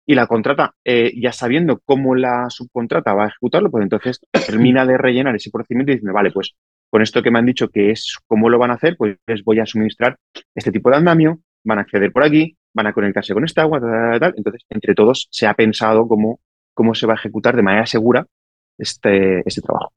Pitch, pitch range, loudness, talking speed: 115 Hz, 105-125 Hz, -16 LUFS, 230 wpm